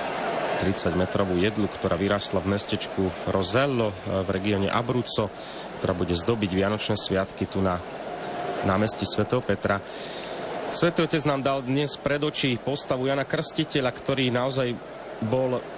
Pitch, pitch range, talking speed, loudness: 110 Hz, 95-135 Hz, 125 wpm, -26 LUFS